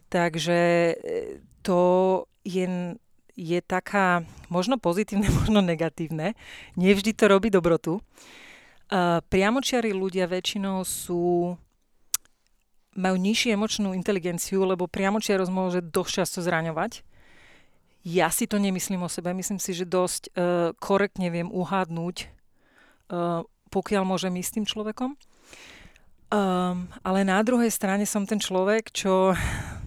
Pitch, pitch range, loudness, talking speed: 185 Hz, 180-205 Hz, -25 LUFS, 115 wpm